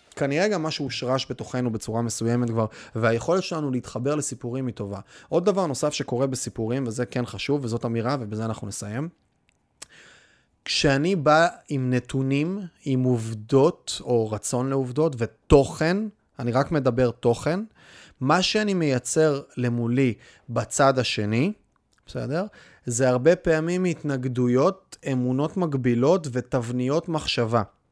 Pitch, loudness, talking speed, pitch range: 130 Hz, -24 LUFS, 120 wpm, 120-155 Hz